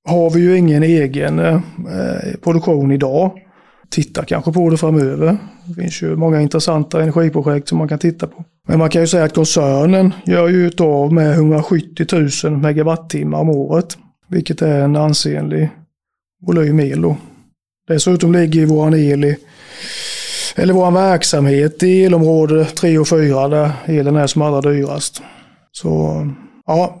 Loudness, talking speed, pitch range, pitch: -14 LUFS, 155 wpm, 150-170 Hz, 160 Hz